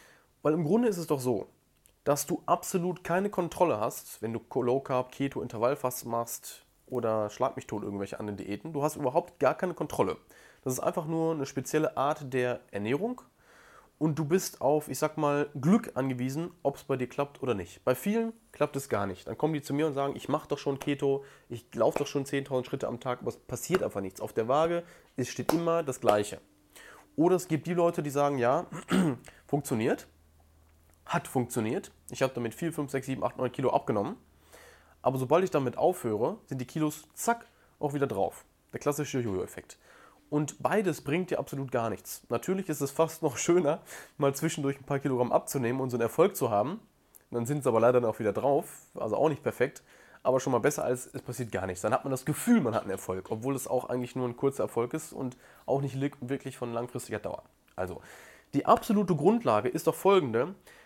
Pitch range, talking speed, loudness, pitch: 125-160 Hz, 210 wpm, -30 LUFS, 140 Hz